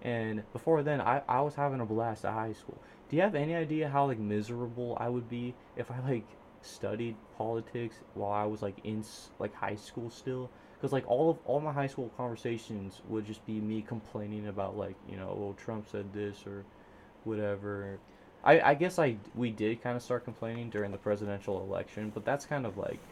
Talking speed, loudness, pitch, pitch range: 210 wpm, -34 LUFS, 110 Hz, 105-125 Hz